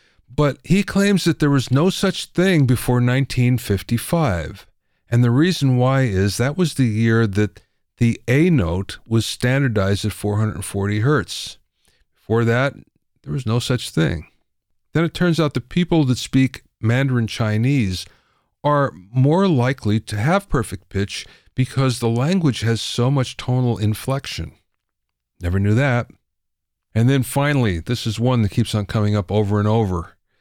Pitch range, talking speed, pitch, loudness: 105-135 Hz, 155 wpm, 120 Hz, -19 LUFS